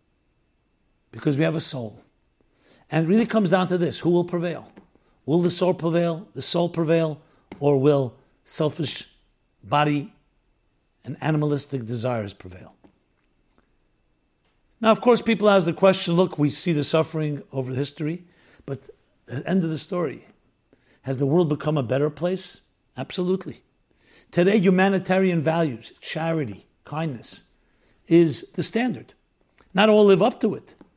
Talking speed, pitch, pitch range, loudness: 140 wpm, 160 Hz, 140-180 Hz, -23 LUFS